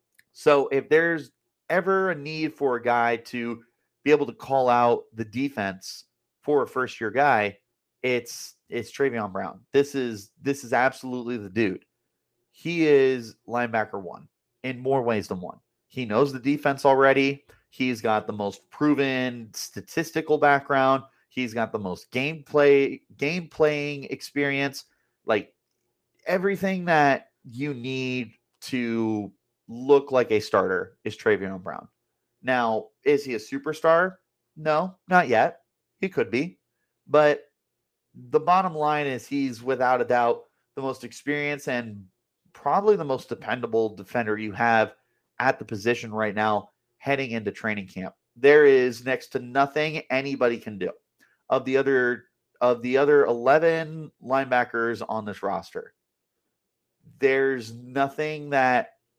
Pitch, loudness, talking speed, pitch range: 135 Hz, -24 LUFS, 140 wpm, 120-150 Hz